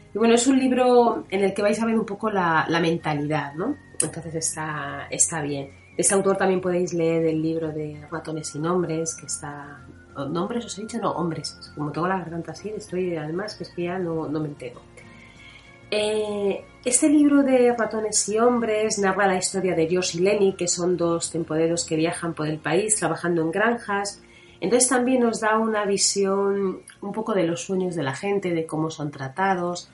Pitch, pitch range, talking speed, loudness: 180 Hz, 160-205 Hz, 200 wpm, -23 LUFS